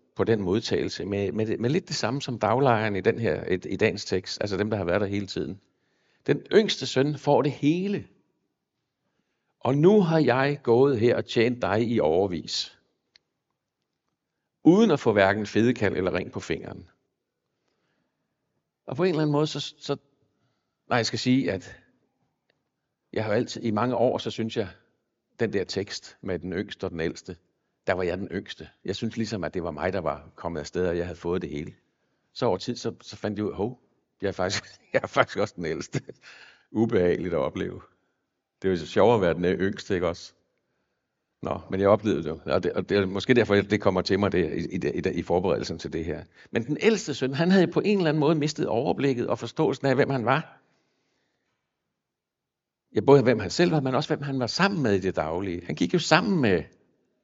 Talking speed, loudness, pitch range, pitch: 210 wpm, -25 LUFS, 105-145 Hz, 120 Hz